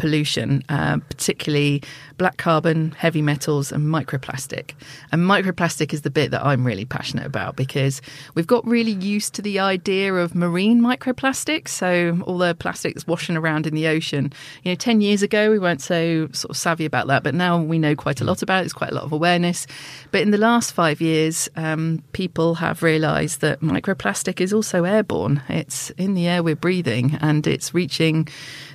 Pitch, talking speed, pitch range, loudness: 160 Hz, 190 wpm, 150-185 Hz, -21 LUFS